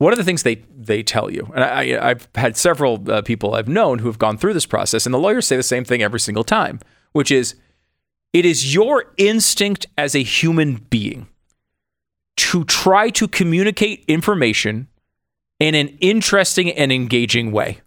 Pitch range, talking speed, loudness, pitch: 115-190 Hz, 180 wpm, -17 LUFS, 140 Hz